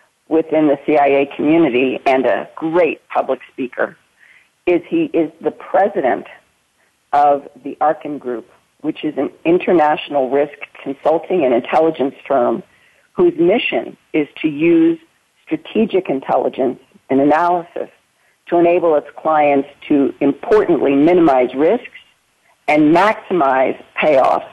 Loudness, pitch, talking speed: -16 LUFS, 170 Hz, 115 wpm